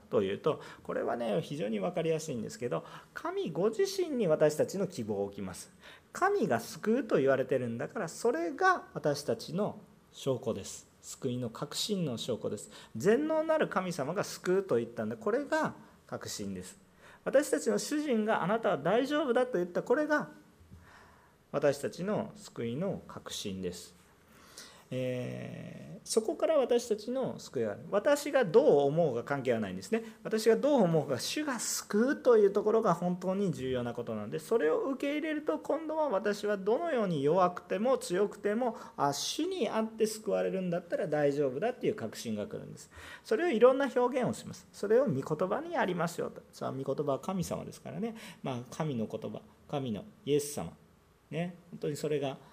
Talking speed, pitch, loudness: 345 characters per minute, 205 Hz, -32 LUFS